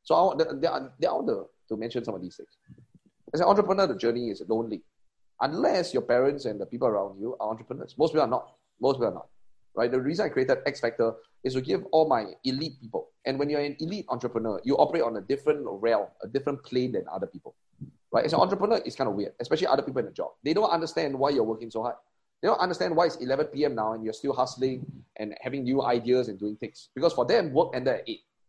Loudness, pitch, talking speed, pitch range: -28 LUFS, 130 Hz, 245 wpm, 115-150 Hz